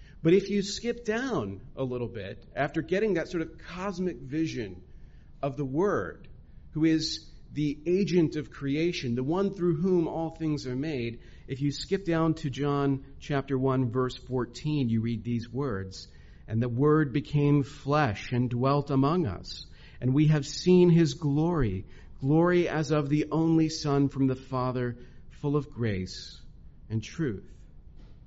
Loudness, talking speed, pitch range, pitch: -28 LUFS, 160 wpm, 125-160 Hz, 140 Hz